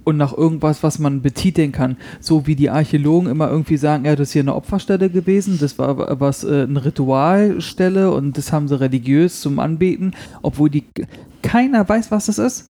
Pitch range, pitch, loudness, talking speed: 145-185 Hz, 155 Hz, -17 LUFS, 195 wpm